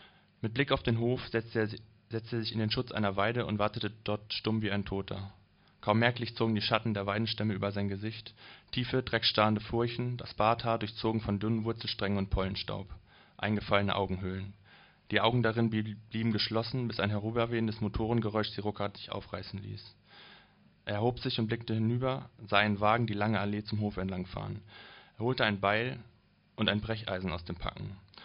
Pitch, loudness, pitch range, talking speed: 110 Hz, -32 LUFS, 100-115 Hz, 170 wpm